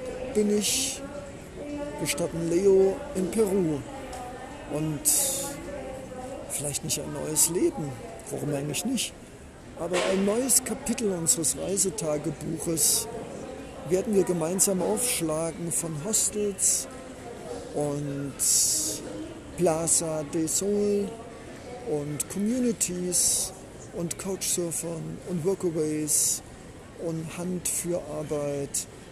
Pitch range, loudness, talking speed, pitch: 160-220 Hz, -26 LUFS, 85 wpm, 180 Hz